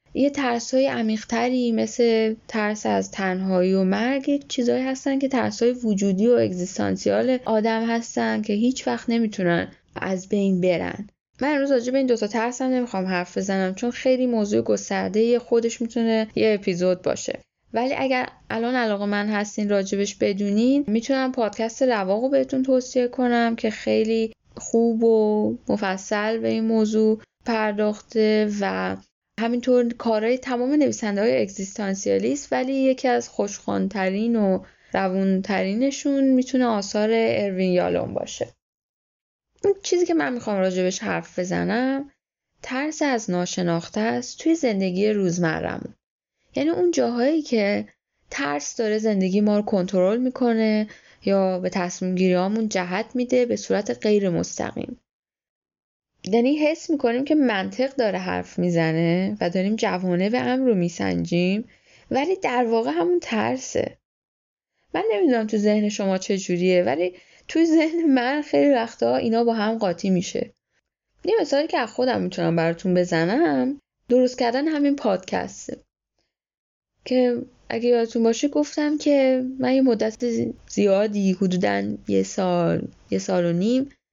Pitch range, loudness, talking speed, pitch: 190-255 Hz, -22 LUFS, 135 wpm, 225 Hz